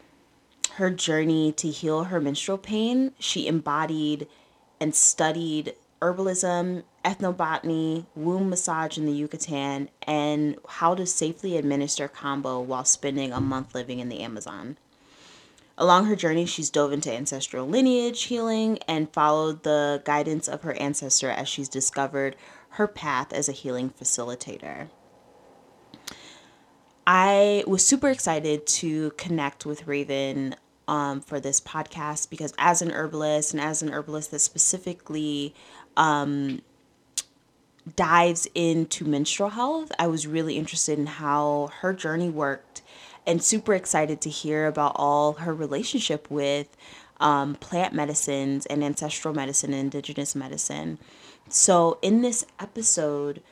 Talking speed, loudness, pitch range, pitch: 130 wpm, -25 LUFS, 145-170 Hz, 155 Hz